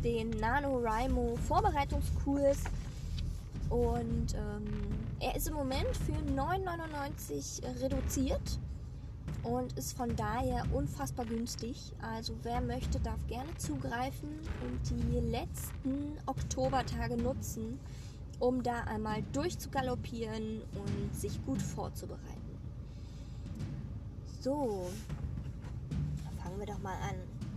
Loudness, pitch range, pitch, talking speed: -37 LUFS, 85-125 Hz, 110 Hz, 95 wpm